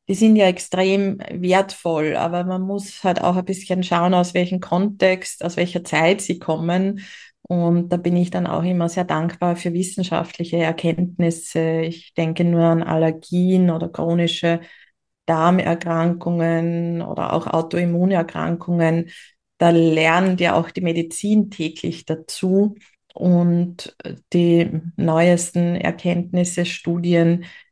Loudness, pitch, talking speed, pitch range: -20 LUFS, 175 Hz, 125 wpm, 170-180 Hz